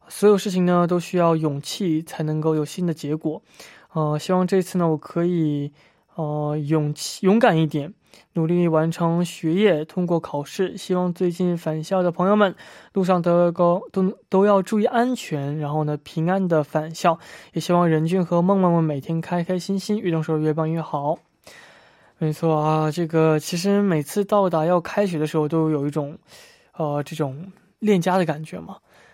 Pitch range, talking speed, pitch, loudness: 155-185 Hz, 260 characters per minute, 170 Hz, -22 LUFS